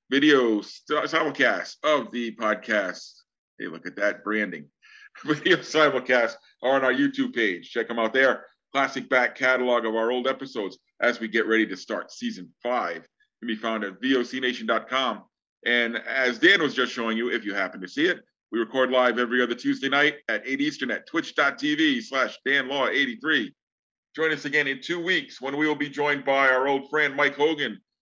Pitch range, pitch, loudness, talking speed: 120-150 Hz, 130 Hz, -24 LUFS, 185 wpm